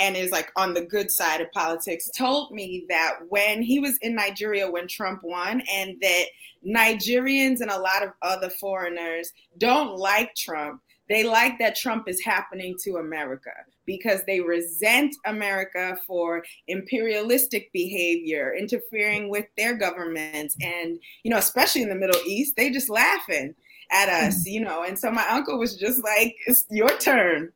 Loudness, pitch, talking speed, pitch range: -23 LUFS, 195 Hz, 165 wpm, 175-225 Hz